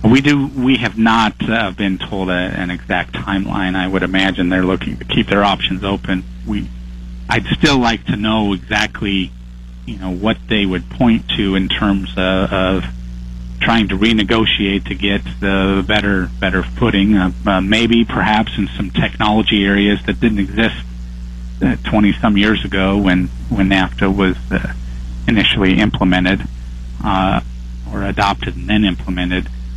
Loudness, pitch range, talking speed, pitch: -15 LUFS, 65-105 Hz, 155 wpm, 95 Hz